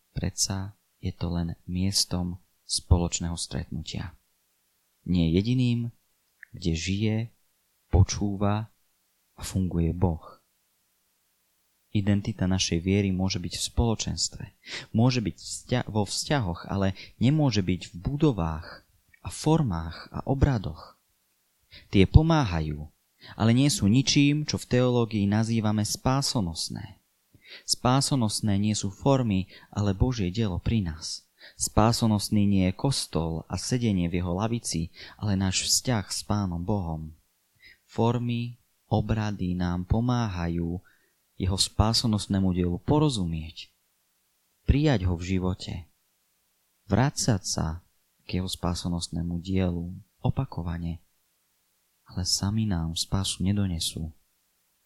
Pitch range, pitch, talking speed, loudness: 90-110 Hz, 95 Hz, 105 wpm, -27 LUFS